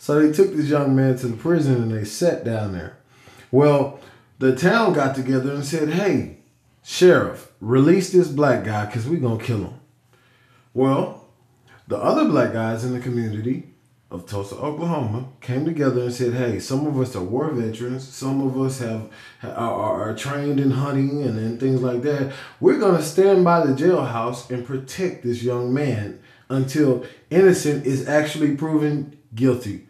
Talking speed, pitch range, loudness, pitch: 175 wpm, 120-150 Hz, -21 LUFS, 130 Hz